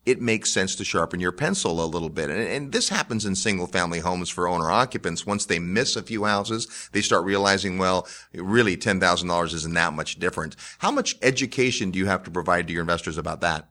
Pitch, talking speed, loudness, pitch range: 95 Hz, 215 wpm, -24 LUFS, 85-105 Hz